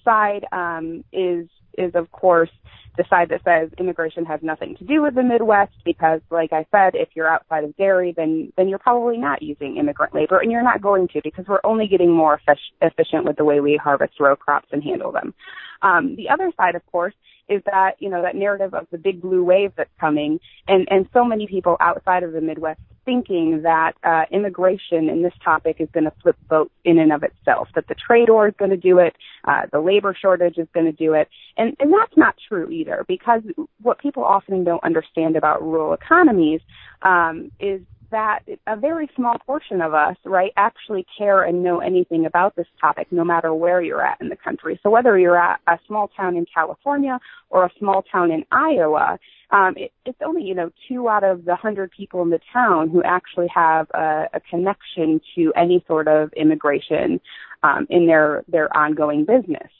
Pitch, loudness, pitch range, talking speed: 180 Hz, -19 LUFS, 160-205 Hz, 210 wpm